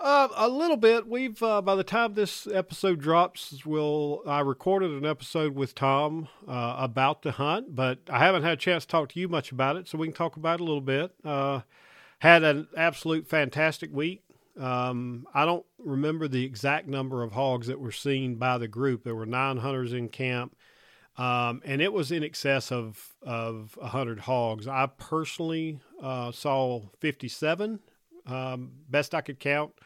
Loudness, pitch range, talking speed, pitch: -28 LUFS, 130-165 Hz, 185 wpm, 145 Hz